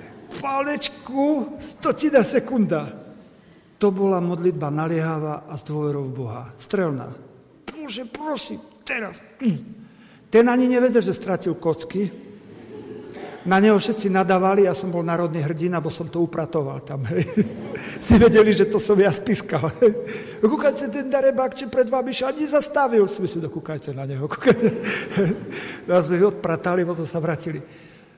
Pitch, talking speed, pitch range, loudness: 195 Hz, 135 wpm, 165-240 Hz, -21 LUFS